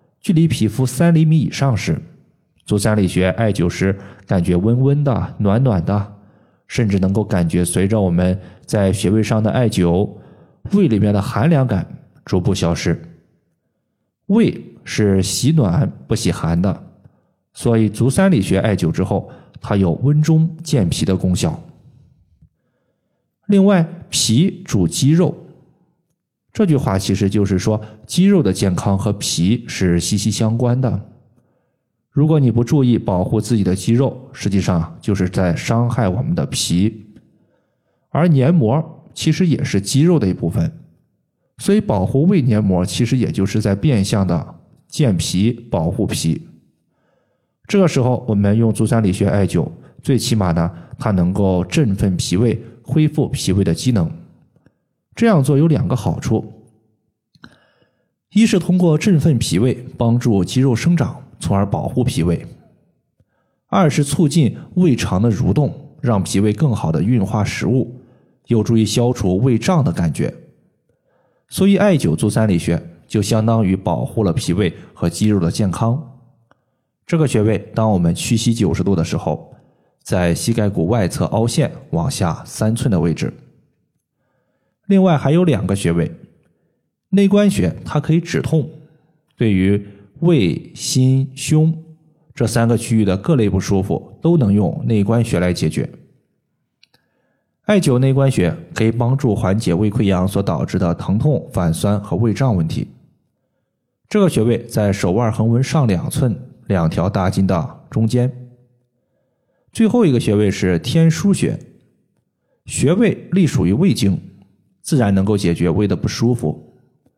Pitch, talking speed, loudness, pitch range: 115 Hz, 215 characters per minute, -17 LUFS, 100-145 Hz